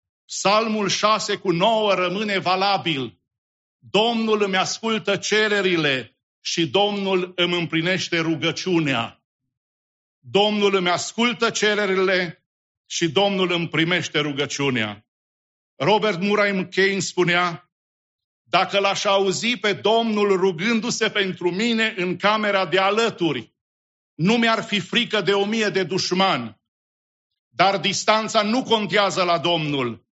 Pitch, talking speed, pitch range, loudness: 190 Hz, 110 wpm, 165-205 Hz, -20 LUFS